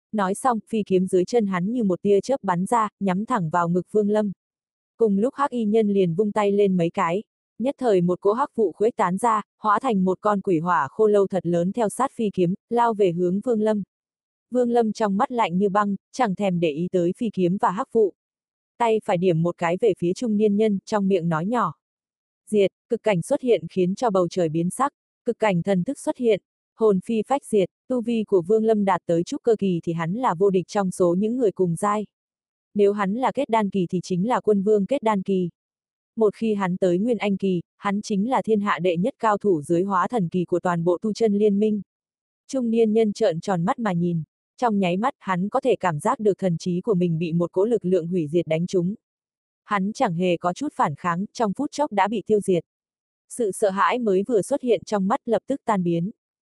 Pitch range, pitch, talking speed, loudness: 180-225 Hz, 205 Hz, 245 wpm, -23 LUFS